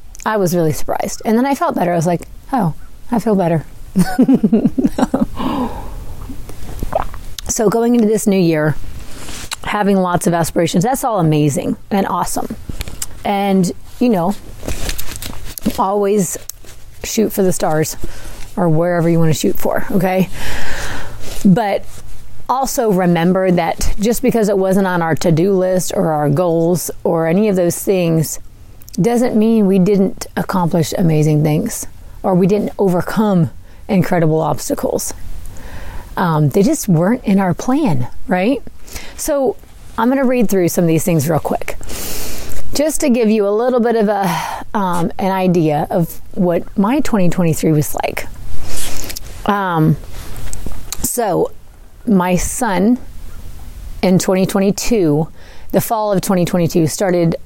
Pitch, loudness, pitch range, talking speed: 180 Hz, -16 LUFS, 155-210 Hz, 135 wpm